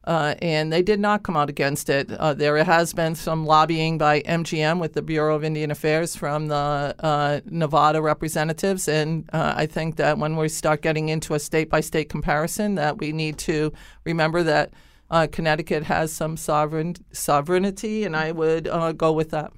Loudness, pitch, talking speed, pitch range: -22 LUFS, 155 Hz, 185 wpm, 150-165 Hz